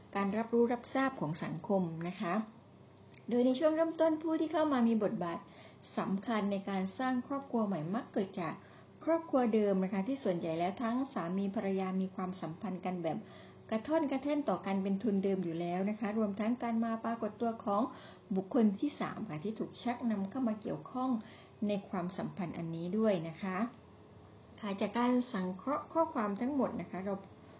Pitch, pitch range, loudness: 210 Hz, 190-245 Hz, -33 LUFS